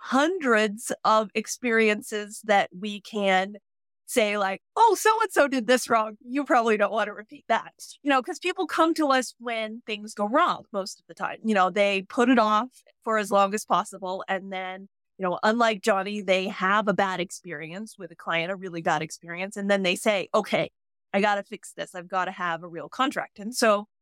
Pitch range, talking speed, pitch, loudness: 190-235 Hz, 210 wpm, 210 Hz, -25 LUFS